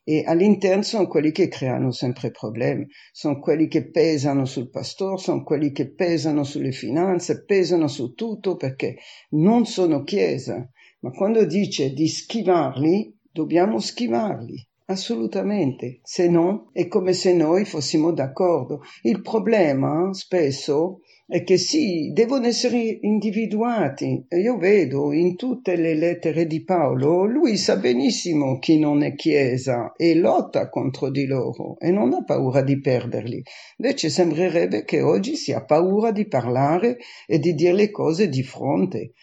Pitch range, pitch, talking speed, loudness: 145-195 Hz, 170 Hz, 145 wpm, -21 LUFS